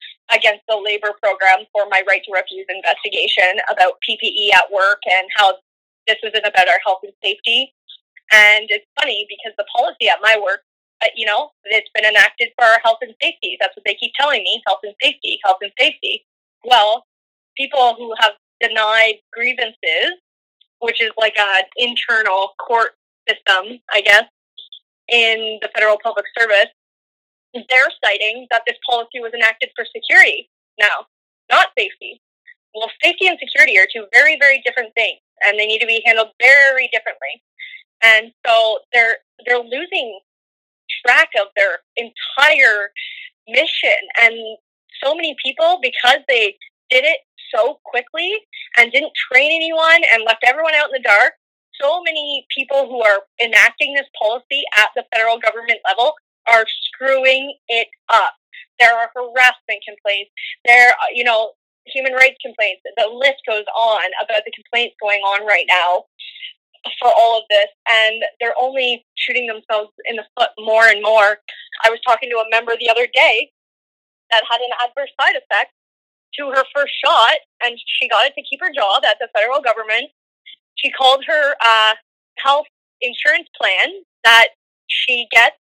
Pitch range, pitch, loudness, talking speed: 220-290 Hz, 235 Hz, -14 LUFS, 160 wpm